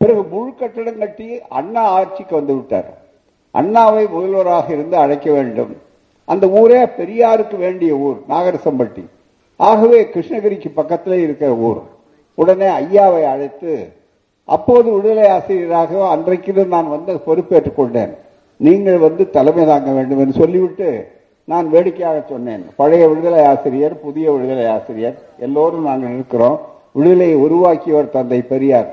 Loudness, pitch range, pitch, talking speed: -14 LUFS, 150-210 Hz, 175 Hz, 120 wpm